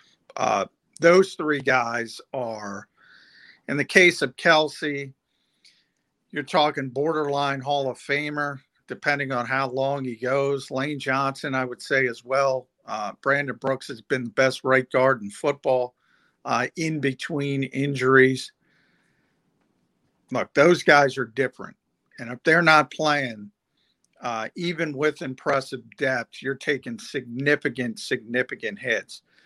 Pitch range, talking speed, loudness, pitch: 130-145 Hz, 130 wpm, -23 LUFS, 135 Hz